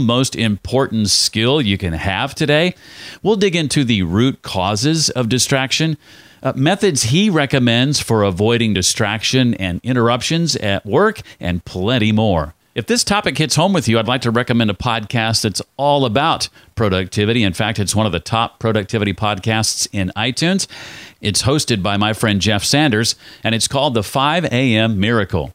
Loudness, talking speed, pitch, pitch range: -16 LUFS, 165 wpm, 115 Hz, 105-135 Hz